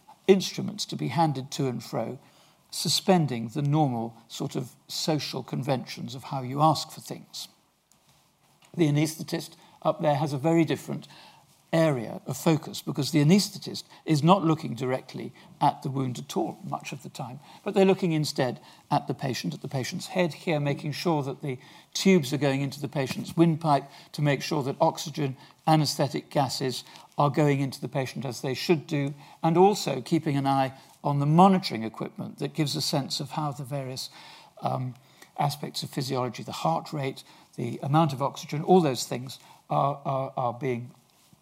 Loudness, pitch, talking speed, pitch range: -27 LUFS, 150 Hz, 175 wpm, 135-165 Hz